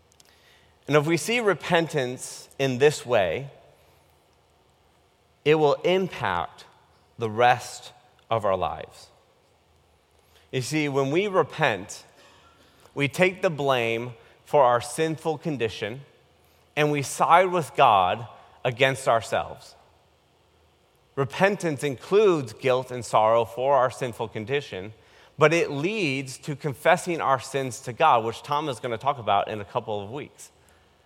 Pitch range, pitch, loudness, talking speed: 110-150 Hz, 130 Hz, -24 LUFS, 130 wpm